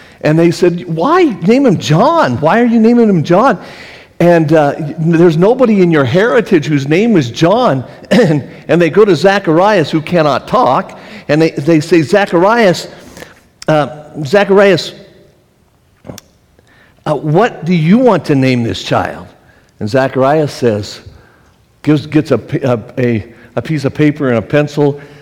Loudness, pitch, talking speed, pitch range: -11 LUFS, 155 Hz, 150 wpm, 140-180 Hz